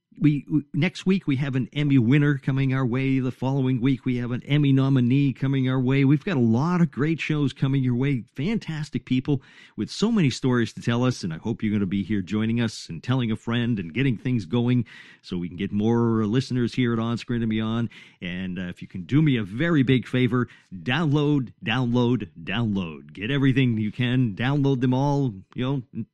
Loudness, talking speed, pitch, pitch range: -24 LUFS, 220 wpm, 125 Hz, 115-140 Hz